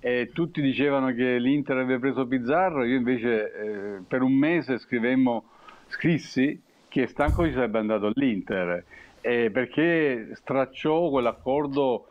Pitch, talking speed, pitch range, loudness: 130 Hz, 130 wpm, 120-140 Hz, -25 LUFS